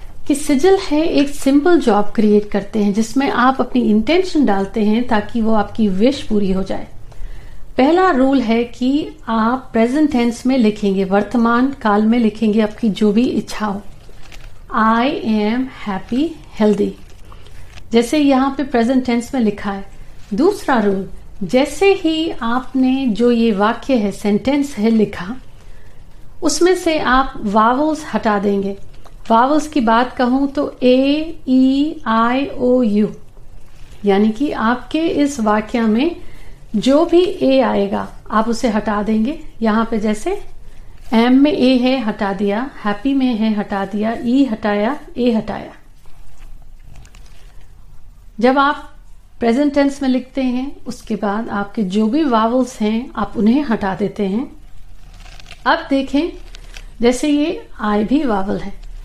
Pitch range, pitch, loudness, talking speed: 210-275 Hz, 235 Hz, -16 LUFS, 135 wpm